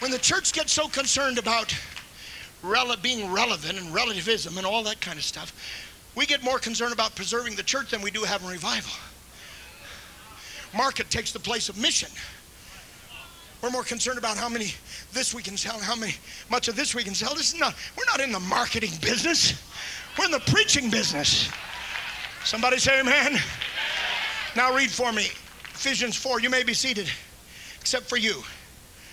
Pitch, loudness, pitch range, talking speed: 240 Hz, -25 LUFS, 215-255 Hz, 175 wpm